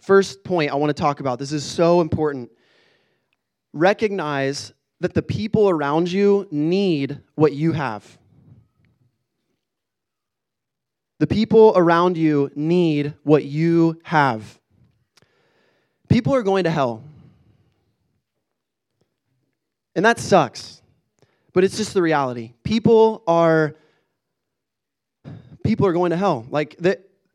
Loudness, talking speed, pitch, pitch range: -19 LUFS, 110 wpm, 155 Hz, 140-185 Hz